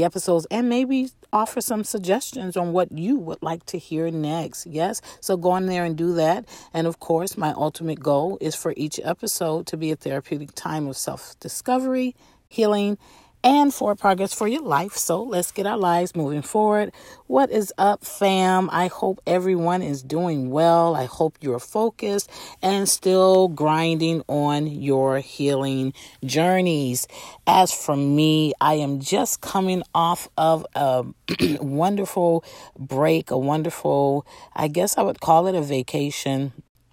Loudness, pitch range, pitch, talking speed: -22 LUFS, 150-195 Hz, 170 Hz, 160 wpm